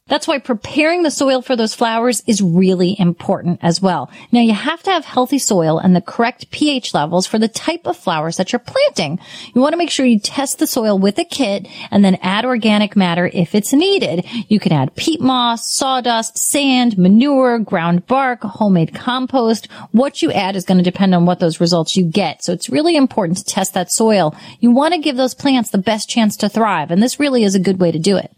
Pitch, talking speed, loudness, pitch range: 220 Hz, 225 wpm, -15 LUFS, 185-260 Hz